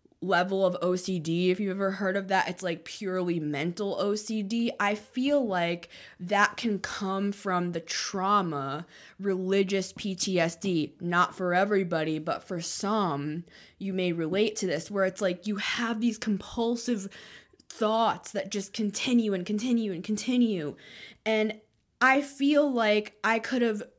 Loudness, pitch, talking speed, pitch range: -28 LUFS, 195 Hz, 145 wpm, 180-215 Hz